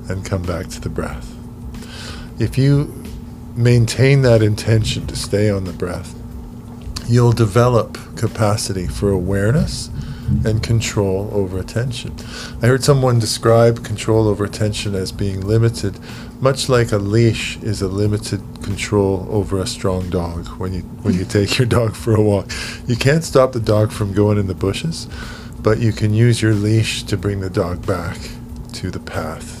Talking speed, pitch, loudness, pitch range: 165 wpm, 110 Hz, -18 LUFS, 100-120 Hz